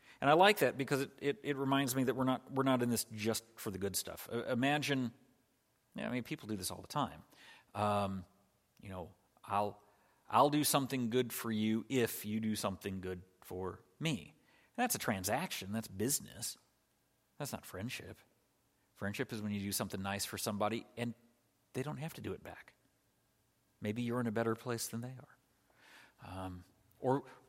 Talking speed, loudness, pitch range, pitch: 190 wpm, -37 LUFS, 100-130 Hz, 115 Hz